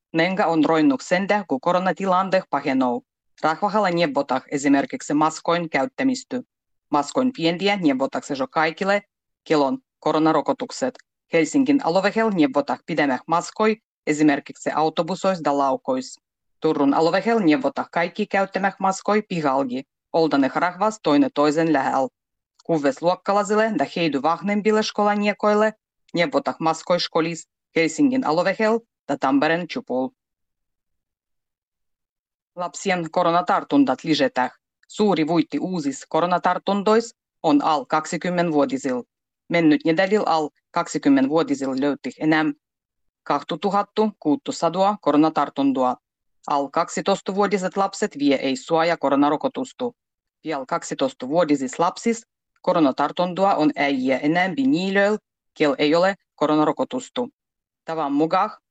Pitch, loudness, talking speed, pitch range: 165 Hz, -21 LUFS, 105 wpm, 145-200 Hz